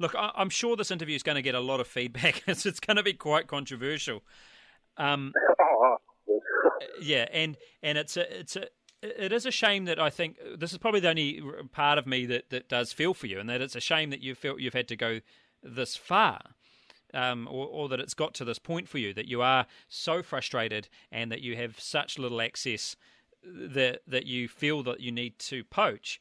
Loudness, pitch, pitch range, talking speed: -29 LUFS, 140 Hz, 125-170 Hz, 215 wpm